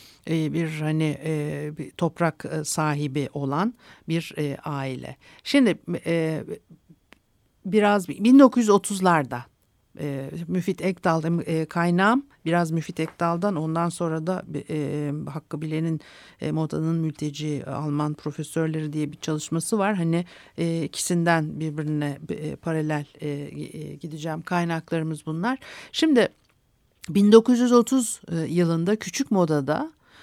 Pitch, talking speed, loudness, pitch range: 165 Hz, 105 wpm, -24 LUFS, 150-185 Hz